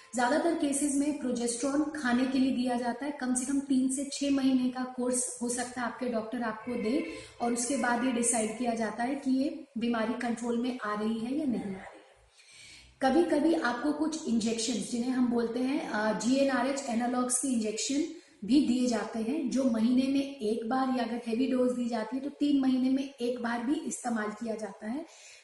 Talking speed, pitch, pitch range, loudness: 200 wpm, 250 Hz, 235-275 Hz, -30 LUFS